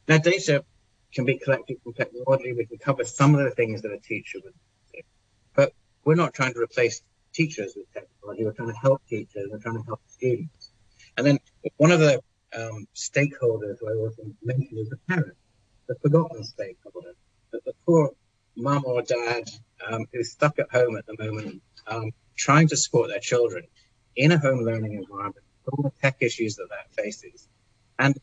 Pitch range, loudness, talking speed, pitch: 110-145 Hz, -25 LUFS, 185 wpm, 120 Hz